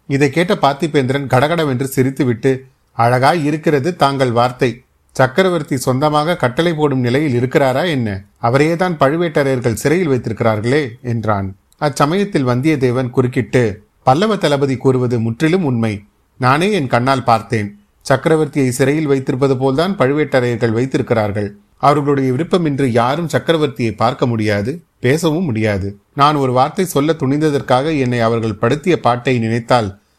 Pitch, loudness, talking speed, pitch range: 135 Hz, -15 LUFS, 115 wpm, 120-150 Hz